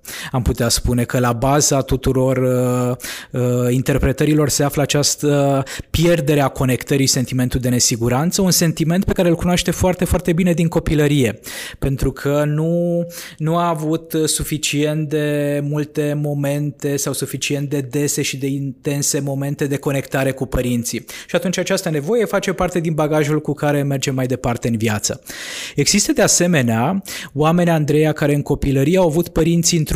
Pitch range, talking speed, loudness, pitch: 135-165 Hz, 160 wpm, -18 LUFS, 145 Hz